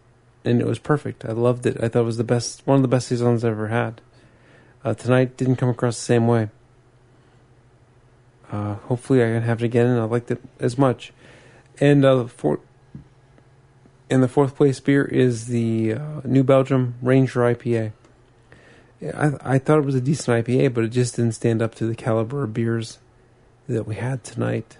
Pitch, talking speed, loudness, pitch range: 120 Hz, 195 wpm, -21 LUFS, 115-130 Hz